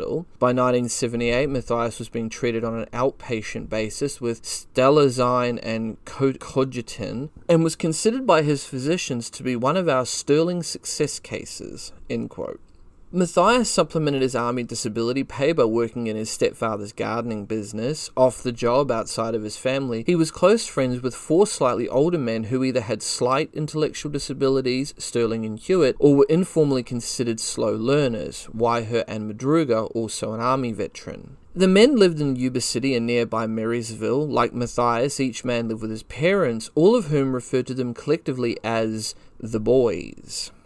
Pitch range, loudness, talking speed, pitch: 115-145 Hz, -23 LUFS, 160 wpm, 125 Hz